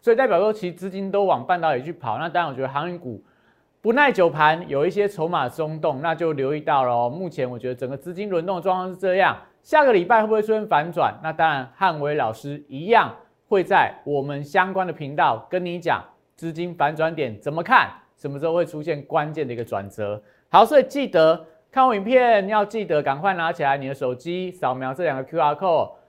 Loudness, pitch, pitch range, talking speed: -21 LUFS, 160 Hz, 140-185 Hz, 335 characters per minute